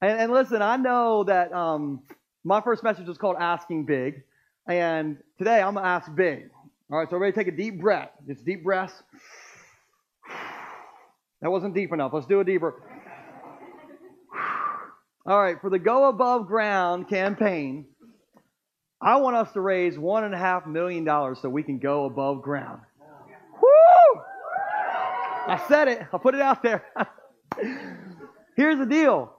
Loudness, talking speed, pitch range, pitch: -23 LUFS, 155 wpm, 170-240 Hz, 195 Hz